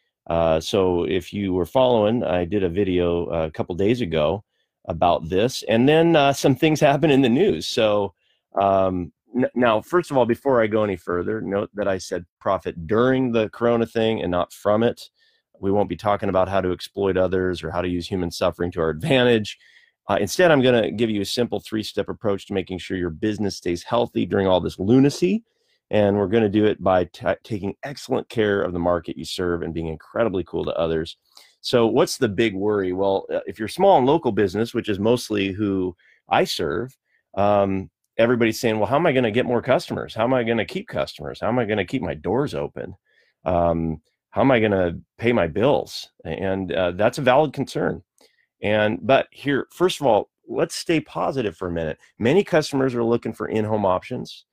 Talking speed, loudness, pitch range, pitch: 210 wpm, -22 LUFS, 90-120 Hz, 105 Hz